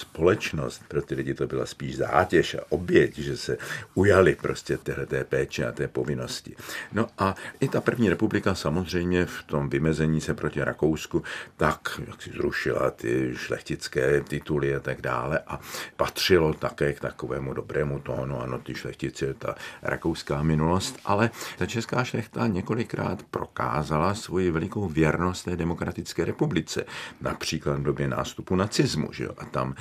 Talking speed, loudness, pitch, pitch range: 155 wpm, -27 LUFS, 80 Hz, 70-90 Hz